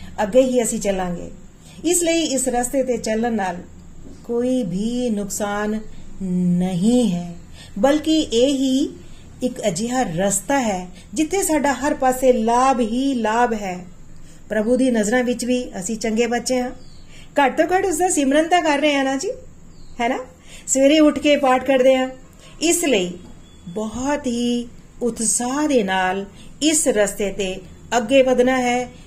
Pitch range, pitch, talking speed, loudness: 210-270 Hz, 245 Hz, 120 wpm, -19 LUFS